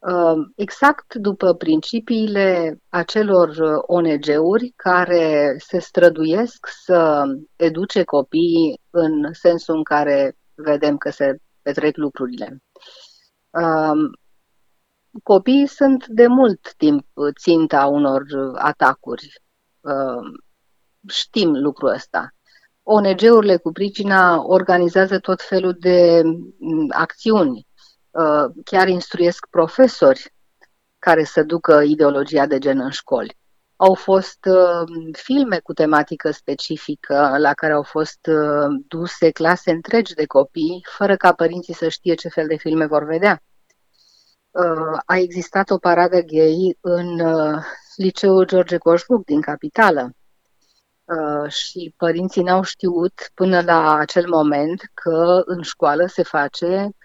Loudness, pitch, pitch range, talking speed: -17 LUFS, 170 Hz, 155-190 Hz, 110 wpm